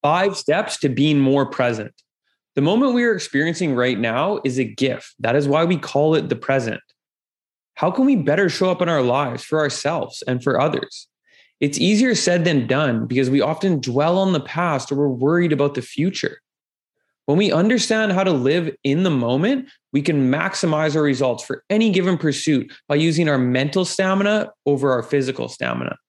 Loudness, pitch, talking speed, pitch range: -19 LUFS, 150 Hz, 190 wpm, 135-185 Hz